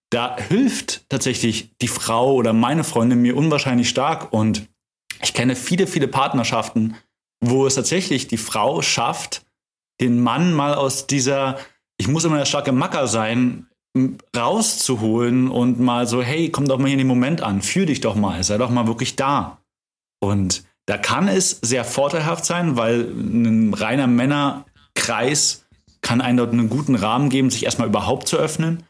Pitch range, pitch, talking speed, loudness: 115-140 Hz, 125 Hz, 165 wpm, -19 LUFS